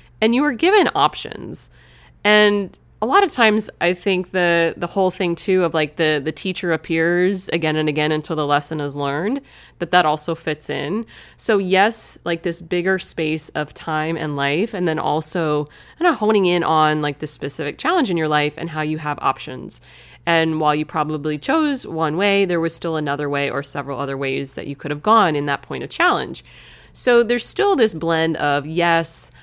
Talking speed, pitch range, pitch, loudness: 205 wpm, 150-190 Hz, 165 Hz, -19 LUFS